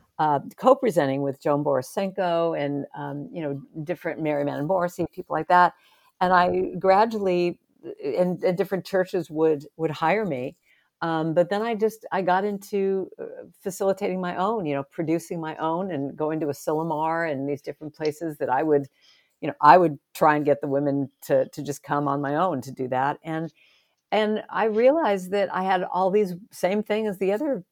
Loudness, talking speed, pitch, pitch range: -24 LUFS, 190 wpm, 175 Hz, 150-195 Hz